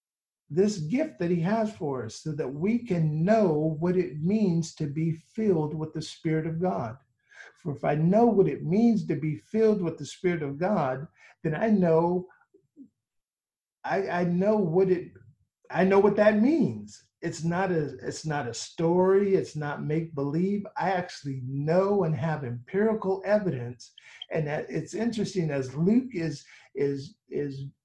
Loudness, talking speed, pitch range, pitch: -27 LUFS, 170 wpm, 155-200 Hz, 175 Hz